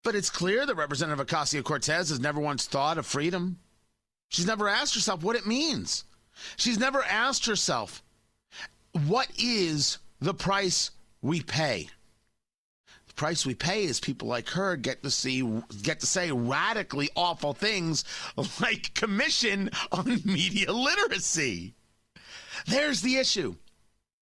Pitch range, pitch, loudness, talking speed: 145-205 Hz, 170 Hz, -28 LUFS, 135 wpm